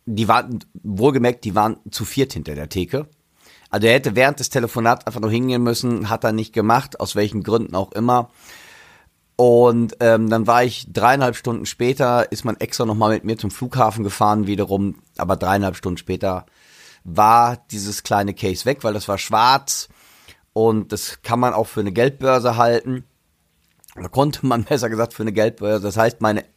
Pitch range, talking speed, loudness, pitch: 105-120 Hz, 180 wpm, -19 LUFS, 110 Hz